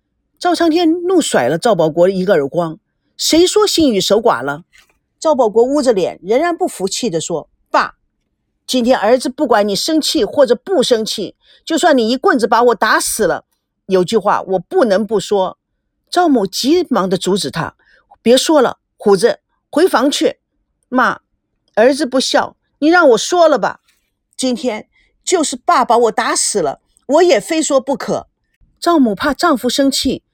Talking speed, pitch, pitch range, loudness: 230 characters per minute, 260 Hz, 210-320 Hz, -14 LUFS